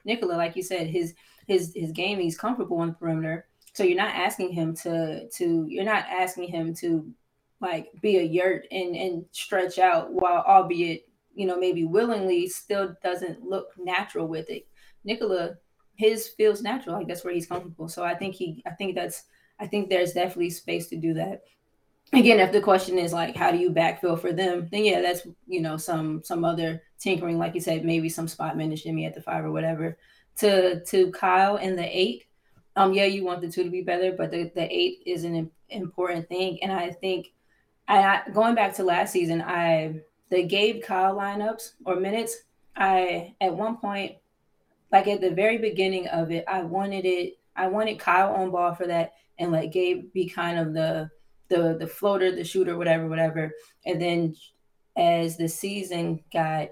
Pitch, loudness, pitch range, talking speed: 180 Hz, -26 LUFS, 170-195 Hz, 195 wpm